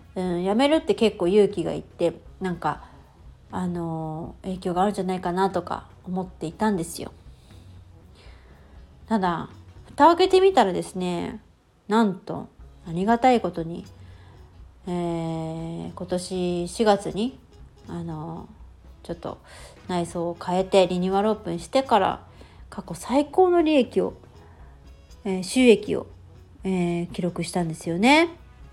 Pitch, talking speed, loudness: 175 Hz, 220 characters per minute, -24 LUFS